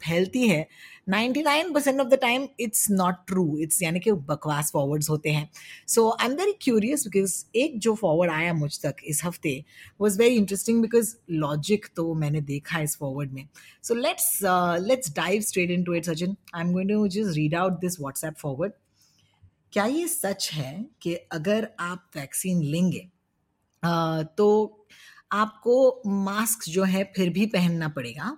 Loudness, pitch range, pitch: -25 LUFS, 155-215 Hz, 180 Hz